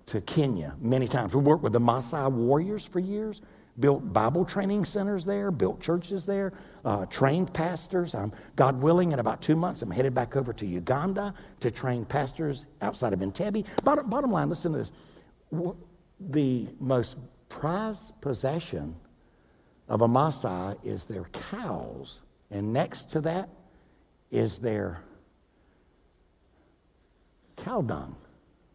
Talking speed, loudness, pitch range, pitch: 140 wpm, -28 LUFS, 120-180 Hz, 145 Hz